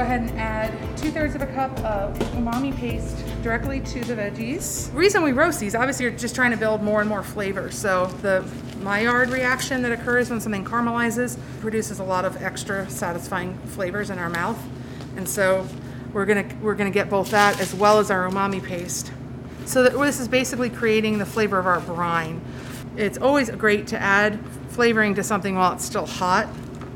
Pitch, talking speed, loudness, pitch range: 205 Hz, 200 wpm, -23 LUFS, 180-235 Hz